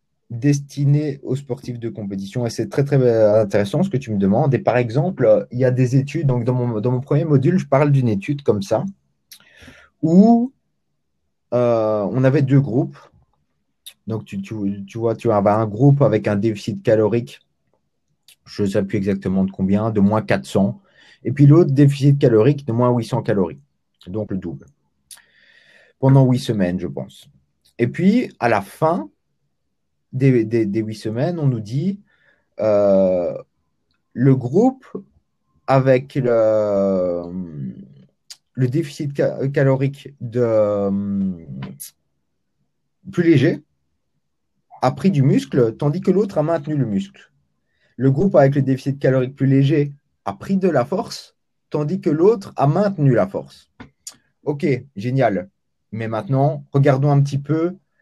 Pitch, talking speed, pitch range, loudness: 120 Hz, 150 wpm, 100-140 Hz, -18 LUFS